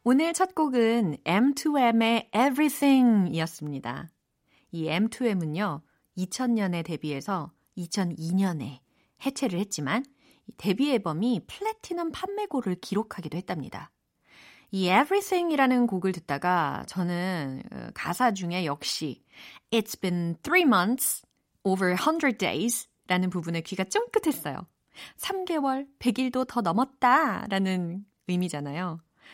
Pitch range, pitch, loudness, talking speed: 175-265 Hz, 205 Hz, -27 LUFS, 310 characters per minute